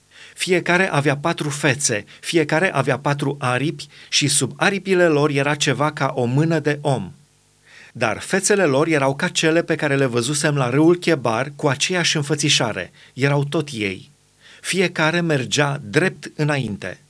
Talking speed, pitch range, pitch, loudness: 145 wpm, 140-165 Hz, 150 Hz, -19 LUFS